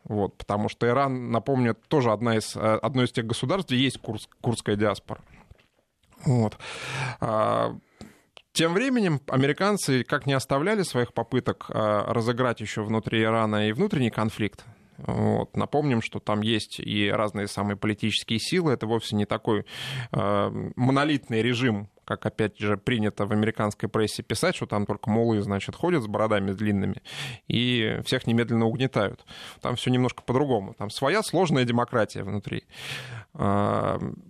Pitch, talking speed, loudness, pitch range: 115 Hz, 140 wpm, -26 LUFS, 105-130 Hz